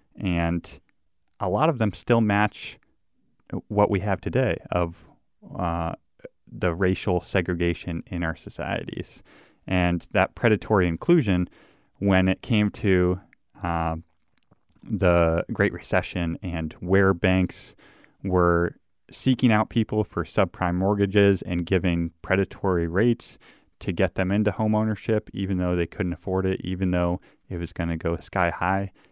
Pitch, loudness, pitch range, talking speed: 95 Hz, -24 LUFS, 85-100 Hz, 135 wpm